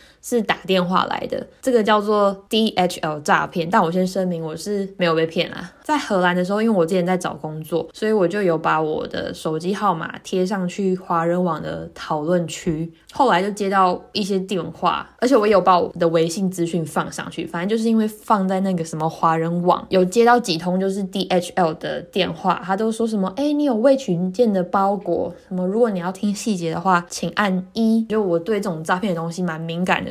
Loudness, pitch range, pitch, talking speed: -20 LUFS, 170-210 Hz, 185 Hz, 320 characters per minute